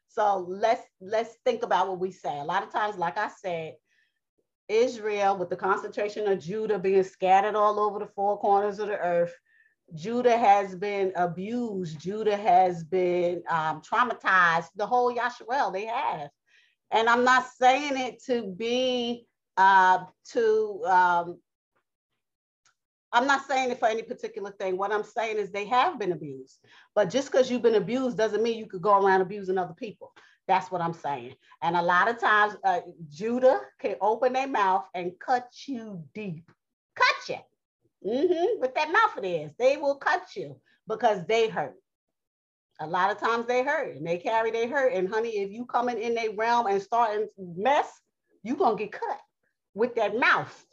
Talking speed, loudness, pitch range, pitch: 175 wpm, -26 LUFS, 190-245 Hz, 215 Hz